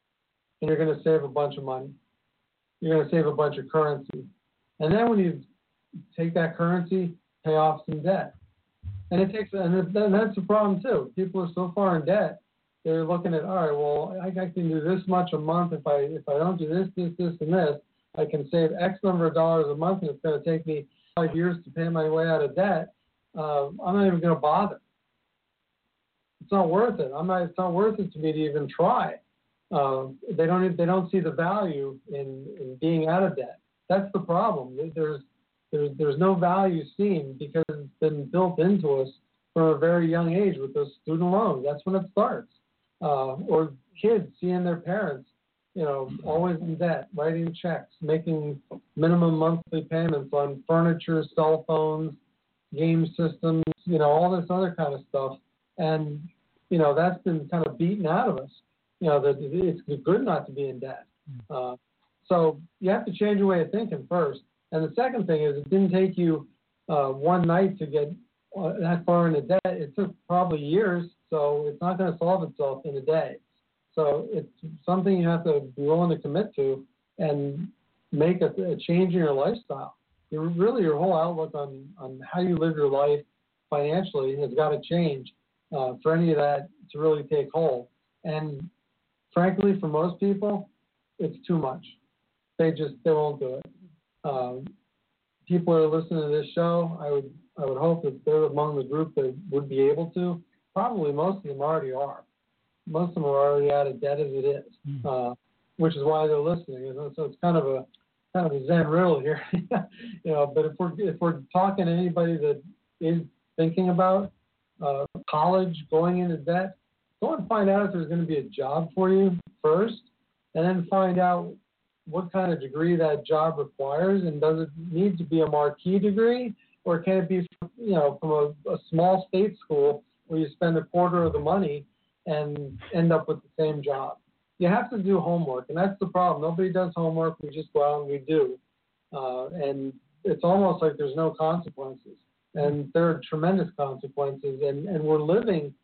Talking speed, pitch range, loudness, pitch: 200 wpm, 150-185 Hz, -26 LUFS, 165 Hz